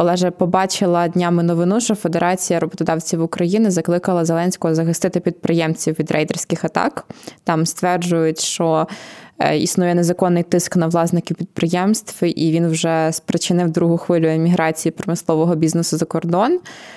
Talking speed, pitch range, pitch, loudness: 125 wpm, 165-180 Hz, 170 Hz, -18 LUFS